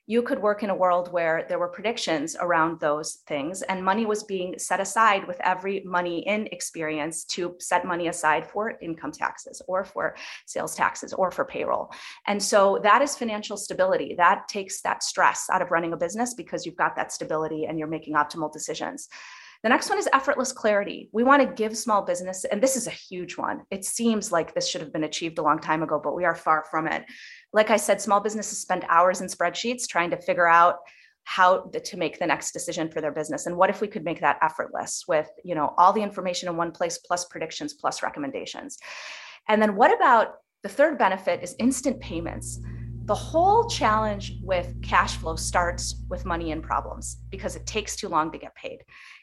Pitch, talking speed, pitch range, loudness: 180 Hz, 210 wpm, 165-215 Hz, -25 LUFS